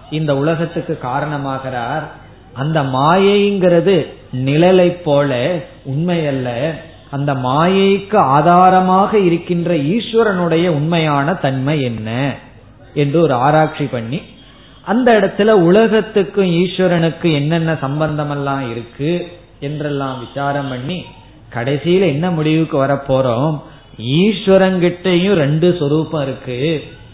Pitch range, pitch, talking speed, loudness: 140-180 Hz, 155 Hz, 90 wpm, -15 LUFS